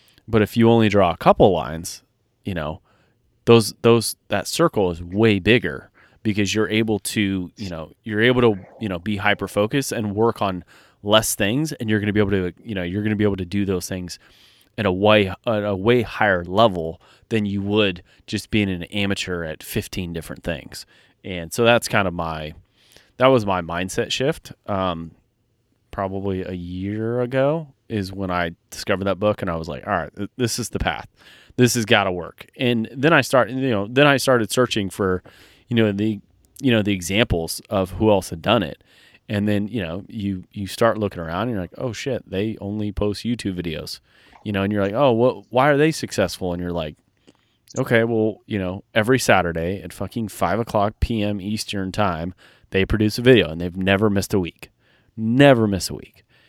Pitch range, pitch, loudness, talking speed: 95-115 Hz, 105 Hz, -21 LUFS, 205 wpm